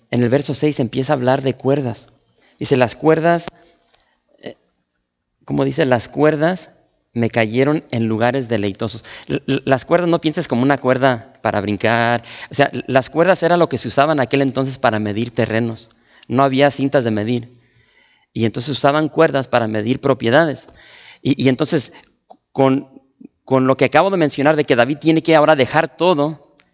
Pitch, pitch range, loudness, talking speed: 135 Hz, 115-150 Hz, -17 LUFS, 165 wpm